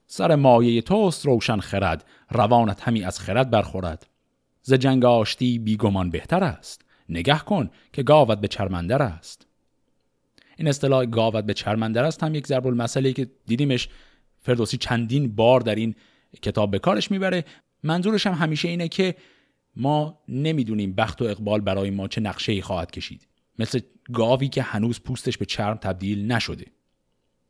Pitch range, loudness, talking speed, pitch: 100-135 Hz, -23 LUFS, 155 wpm, 115 Hz